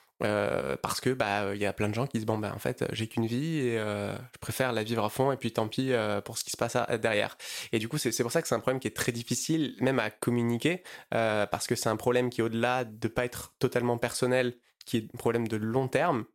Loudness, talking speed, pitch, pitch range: -30 LUFS, 285 wpm, 120 Hz, 110-125 Hz